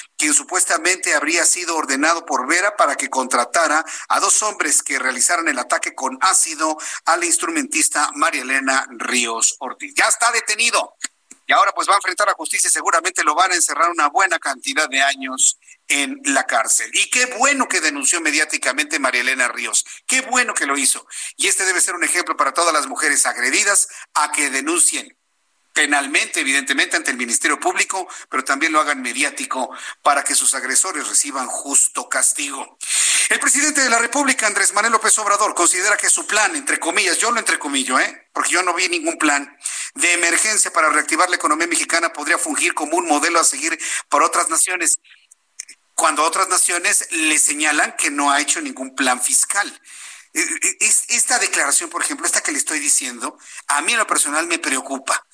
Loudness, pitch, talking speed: -16 LUFS, 205 Hz, 180 wpm